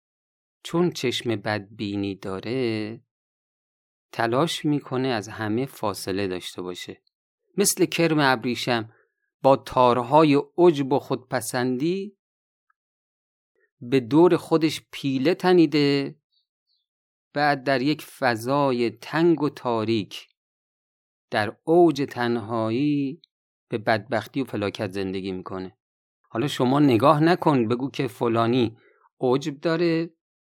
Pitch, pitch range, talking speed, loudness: 130 Hz, 115-155 Hz, 95 wpm, -23 LUFS